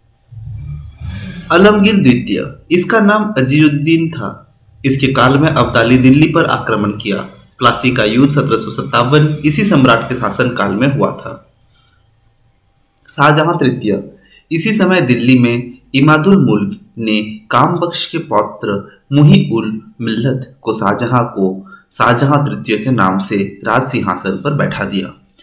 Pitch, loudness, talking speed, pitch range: 125 Hz, -12 LUFS, 125 wpm, 110-150 Hz